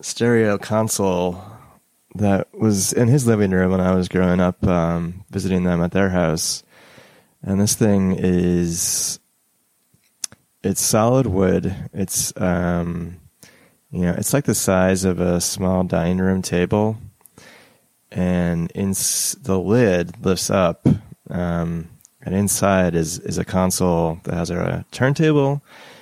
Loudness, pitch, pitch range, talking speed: -19 LUFS, 95 Hz, 90-105 Hz, 130 wpm